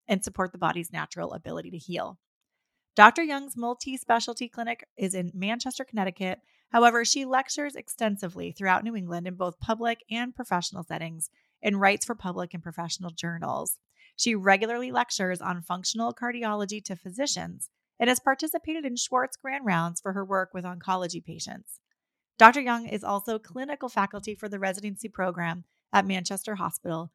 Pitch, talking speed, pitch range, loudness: 210 Hz, 155 wpm, 185-240 Hz, -27 LUFS